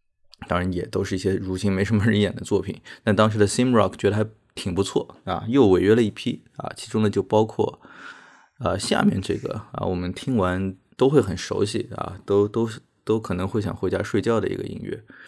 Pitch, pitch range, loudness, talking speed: 100 Hz, 95-110 Hz, -23 LUFS, 320 characters per minute